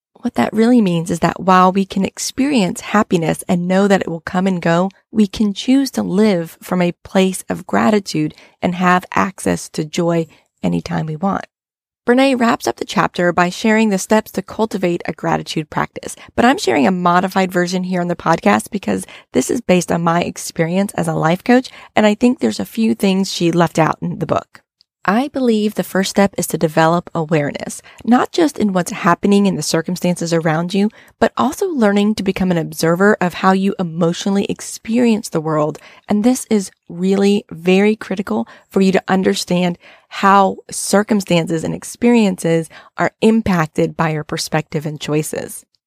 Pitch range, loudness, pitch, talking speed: 170-215 Hz, -16 LUFS, 190 Hz, 180 wpm